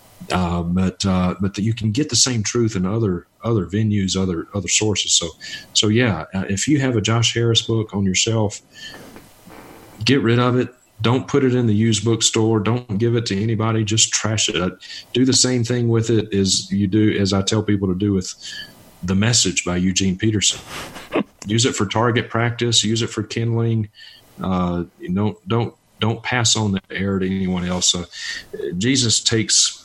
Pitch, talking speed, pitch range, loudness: 110 Hz, 195 wpm, 95-115 Hz, -19 LUFS